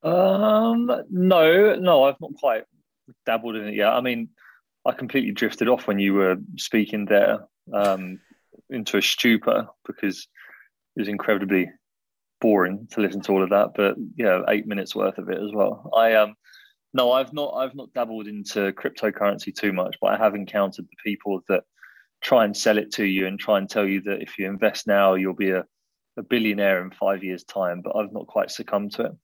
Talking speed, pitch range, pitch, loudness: 200 wpm, 100-115 Hz, 105 Hz, -22 LUFS